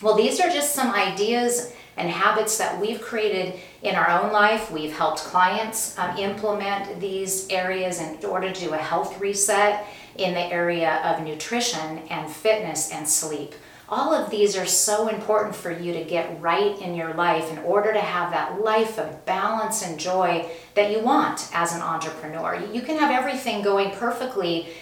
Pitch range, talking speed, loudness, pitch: 170-215 Hz, 180 wpm, -23 LUFS, 195 Hz